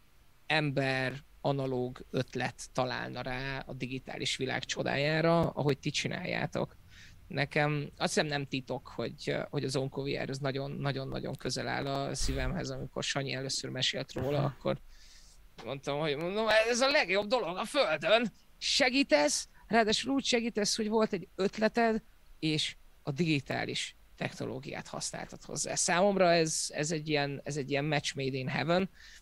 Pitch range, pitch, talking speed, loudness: 135-195 Hz, 150 Hz, 140 wpm, -32 LUFS